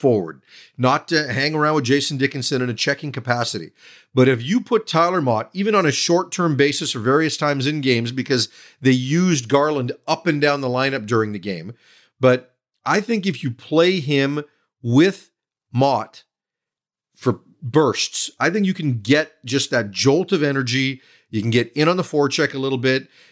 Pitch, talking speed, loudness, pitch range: 140 Hz, 185 wpm, -19 LUFS, 130-155 Hz